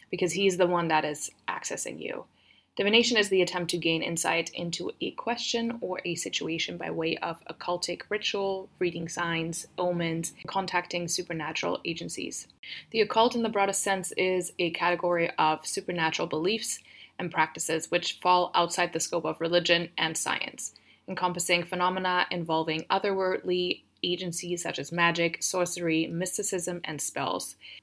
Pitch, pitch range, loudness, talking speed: 175 Hz, 165-185 Hz, -28 LUFS, 145 wpm